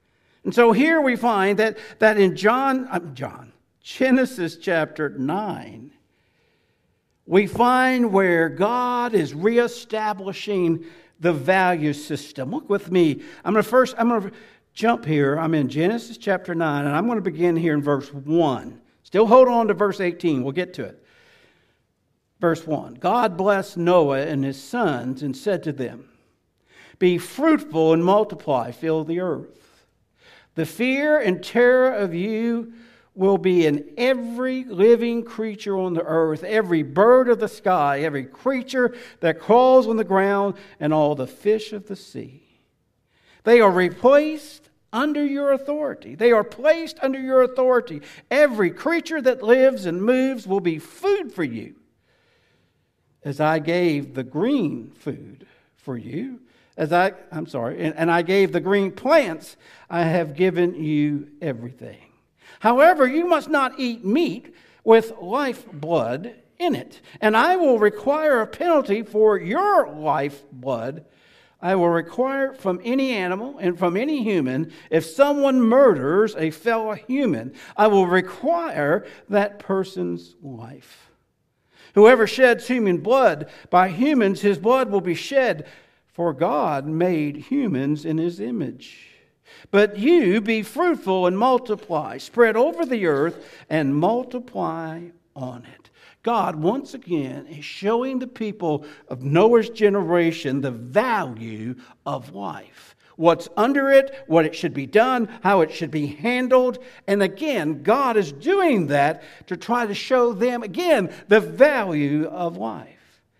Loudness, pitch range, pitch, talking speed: -20 LUFS, 165-245 Hz, 200 Hz, 145 wpm